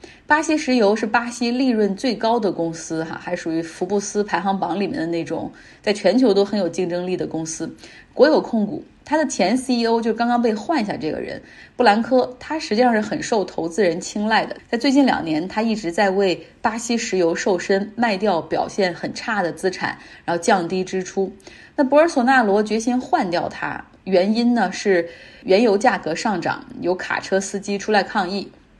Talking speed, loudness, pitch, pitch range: 285 characters per minute, -20 LUFS, 205 Hz, 185-240 Hz